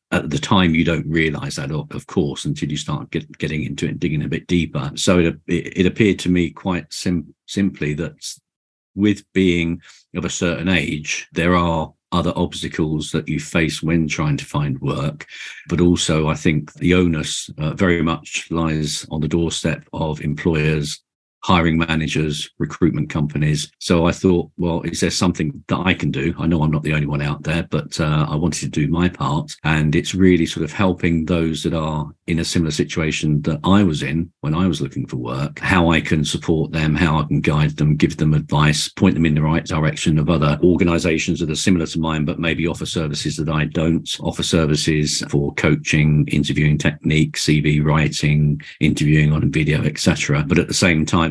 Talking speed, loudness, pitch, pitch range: 200 wpm, -19 LUFS, 80 Hz, 75-85 Hz